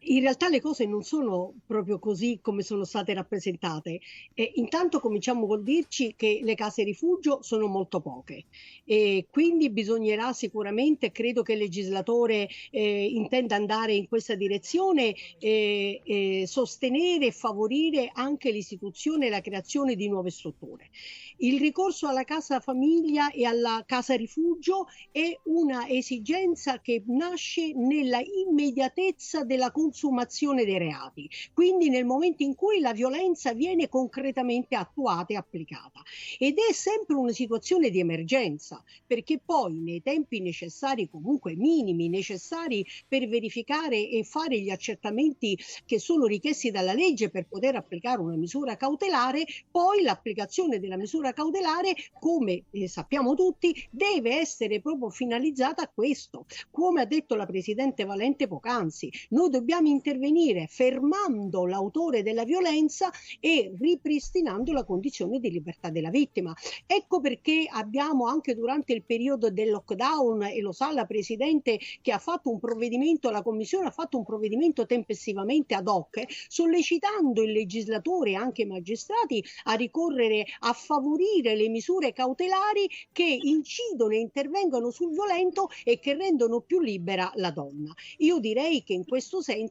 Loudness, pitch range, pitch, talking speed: -27 LUFS, 215-310 Hz, 250 Hz, 145 wpm